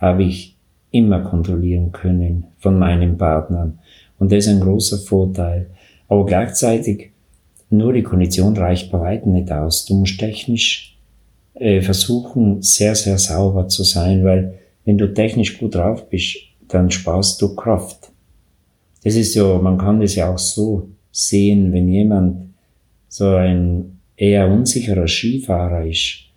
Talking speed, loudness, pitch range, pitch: 145 wpm, -16 LUFS, 90-105 Hz, 95 Hz